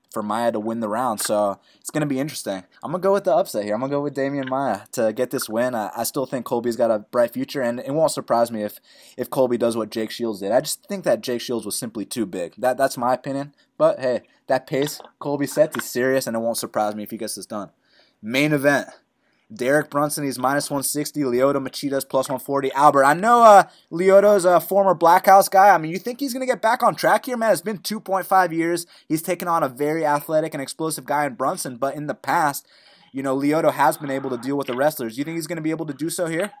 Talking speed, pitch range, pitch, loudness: 260 wpm, 125-170 Hz, 145 Hz, -21 LUFS